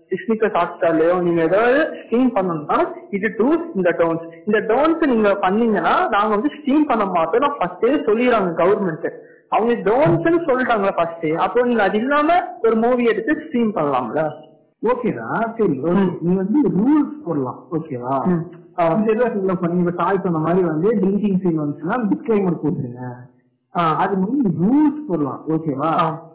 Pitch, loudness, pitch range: 195 Hz, -19 LUFS, 165-240 Hz